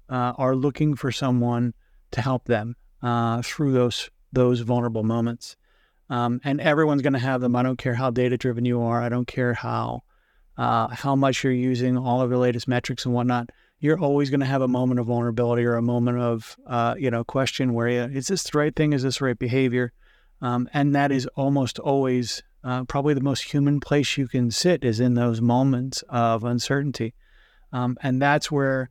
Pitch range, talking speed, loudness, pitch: 120-135 Hz, 205 wpm, -23 LUFS, 125 Hz